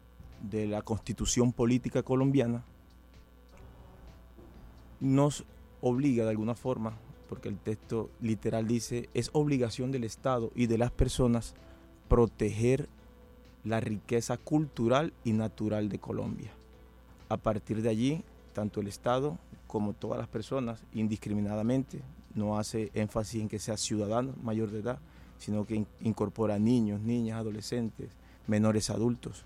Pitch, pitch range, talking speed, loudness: 110 Hz, 105-125 Hz, 125 wpm, -32 LUFS